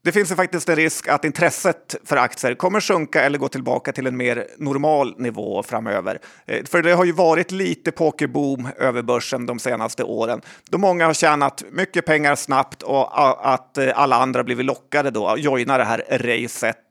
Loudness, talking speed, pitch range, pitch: -20 LUFS, 185 wpm, 130-170 Hz, 145 Hz